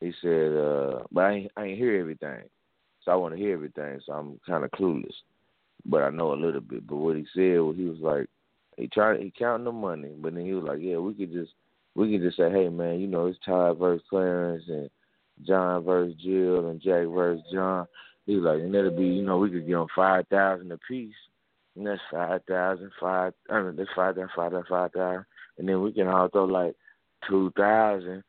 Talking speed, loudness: 225 wpm, -27 LUFS